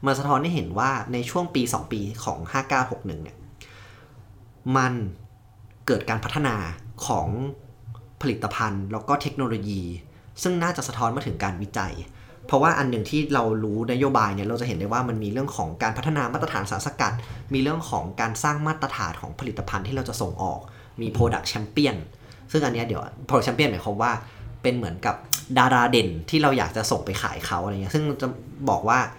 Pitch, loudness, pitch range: 115 Hz, -25 LUFS, 105-135 Hz